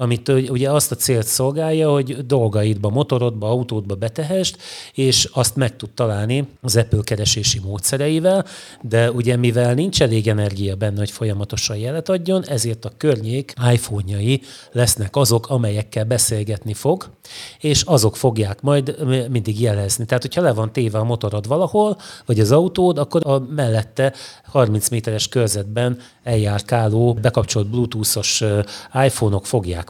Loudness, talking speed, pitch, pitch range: -19 LUFS, 135 wpm, 120 Hz, 110-135 Hz